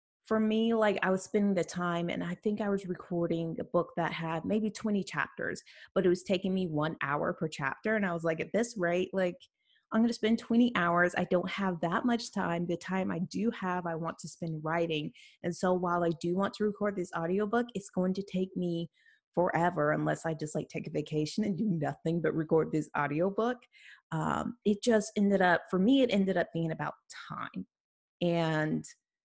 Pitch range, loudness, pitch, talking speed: 165-210 Hz, -31 LUFS, 180 Hz, 215 wpm